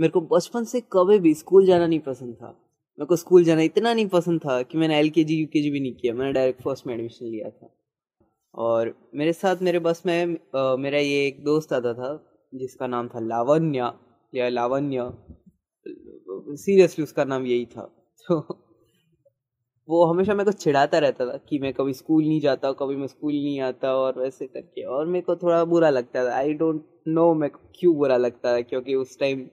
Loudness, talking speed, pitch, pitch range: -23 LUFS, 195 wpm, 150 Hz, 130-170 Hz